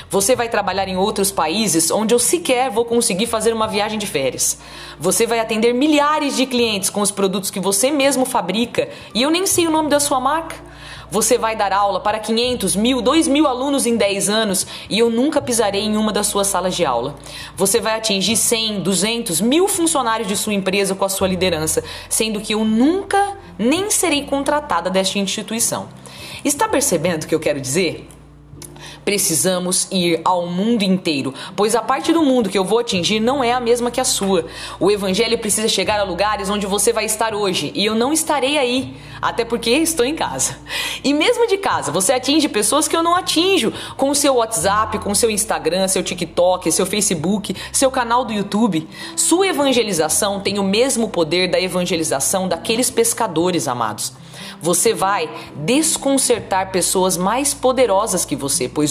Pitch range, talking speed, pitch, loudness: 190-255 Hz, 185 wpm, 215 Hz, -17 LUFS